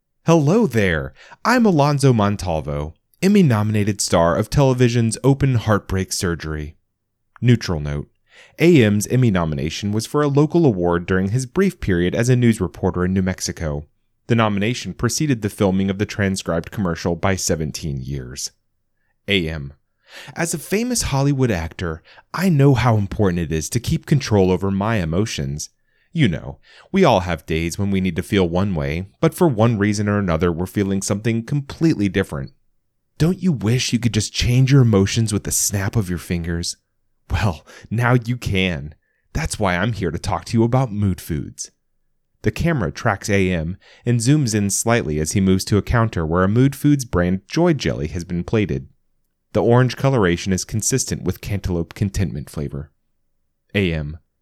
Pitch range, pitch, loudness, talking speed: 90-120 Hz, 100 Hz, -19 LUFS, 170 wpm